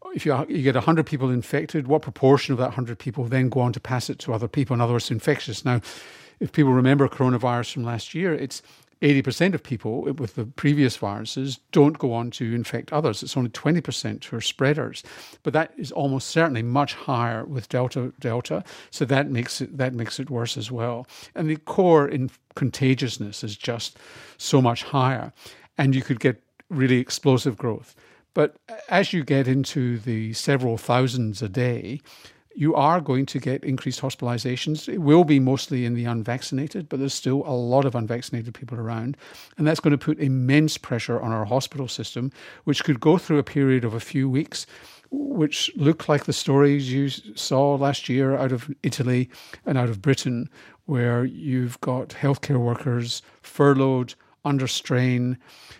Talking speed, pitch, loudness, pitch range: 185 wpm, 130 Hz, -23 LUFS, 120-145 Hz